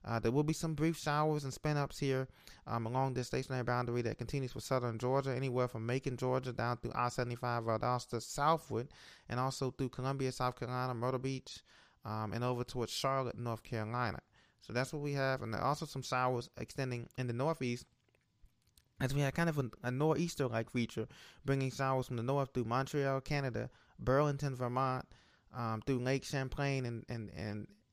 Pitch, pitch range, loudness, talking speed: 130 Hz, 120-135 Hz, -37 LUFS, 190 wpm